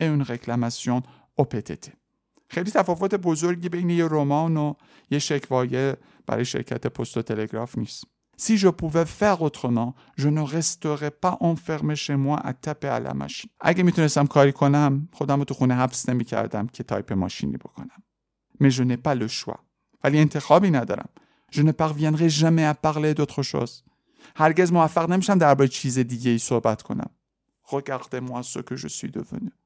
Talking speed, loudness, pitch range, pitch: 155 wpm, -23 LUFS, 125-160 Hz, 145 Hz